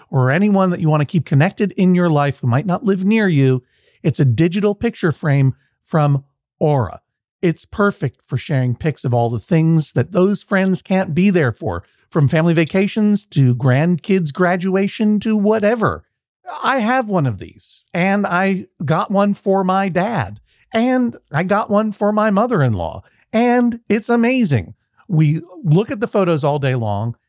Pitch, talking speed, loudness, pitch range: 175 Hz, 175 wpm, -17 LUFS, 140-200 Hz